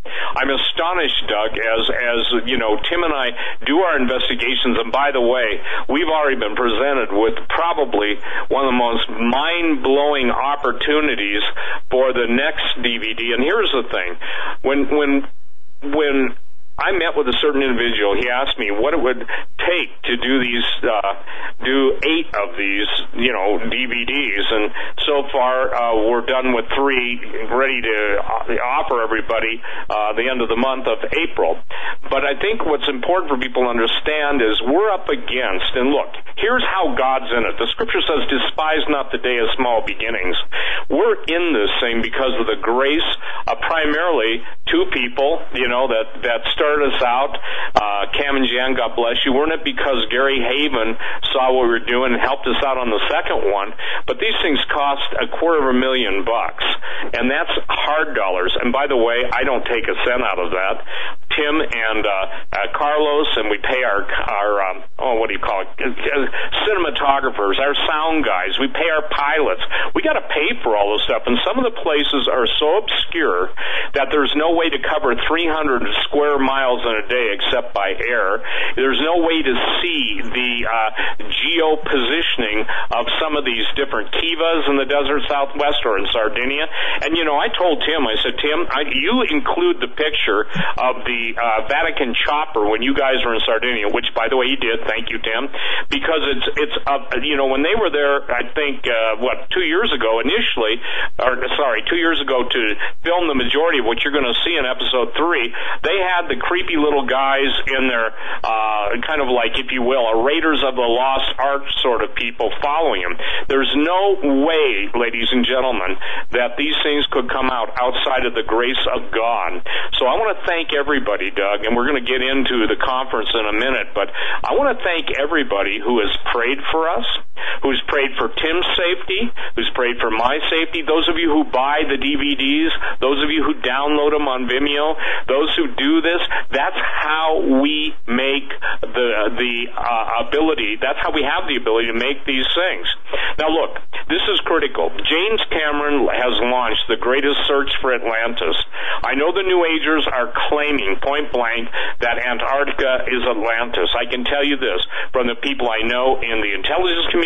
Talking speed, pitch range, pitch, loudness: 190 wpm, 120-150 Hz, 135 Hz, -18 LUFS